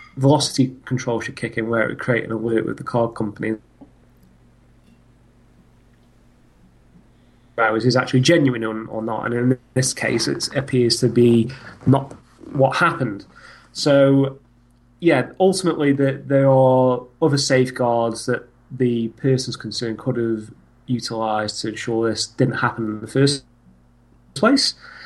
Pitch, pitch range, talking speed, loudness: 120 Hz, 115-135 Hz, 130 wpm, -20 LUFS